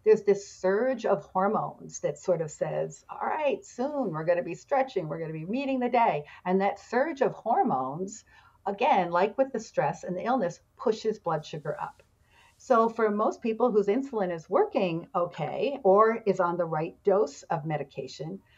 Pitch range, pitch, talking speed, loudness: 175-245 Hz, 195 Hz, 185 wpm, -28 LUFS